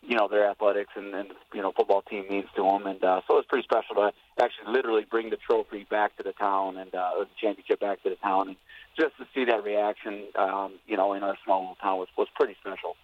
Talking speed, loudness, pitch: 260 wpm, -28 LUFS, 105 Hz